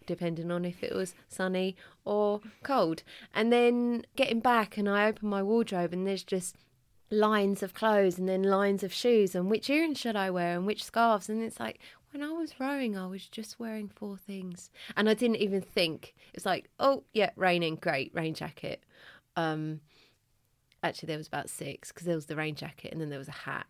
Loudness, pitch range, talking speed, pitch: -31 LUFS, 170-220 Hz, 205 wpm, 195 Hz